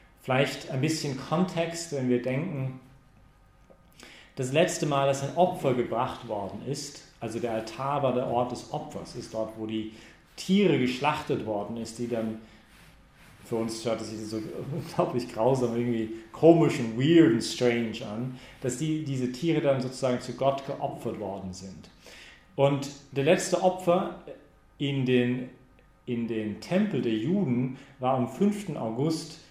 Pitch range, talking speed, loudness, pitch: 115-150 Hz, 155 wpm, -28 LUFS, 130 Hz